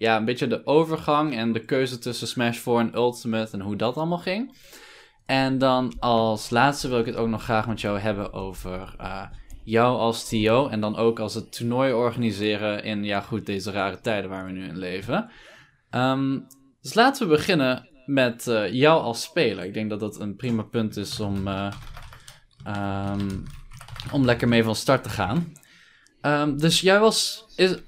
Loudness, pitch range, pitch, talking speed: -24 LUFS, 105-135 Hz, 115 Hz, 185 wpm